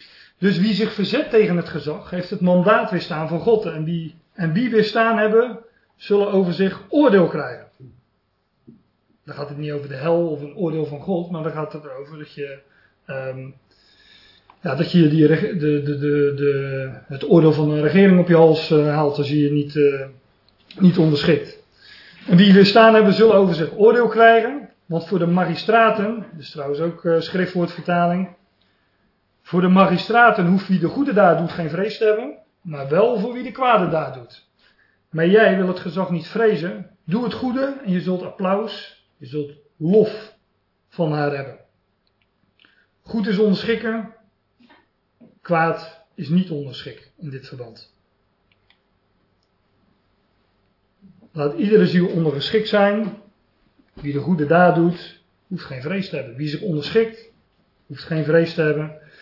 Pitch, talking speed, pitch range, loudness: 170 Hz, 165 wpm, 145-205 Hz, -18 LUFS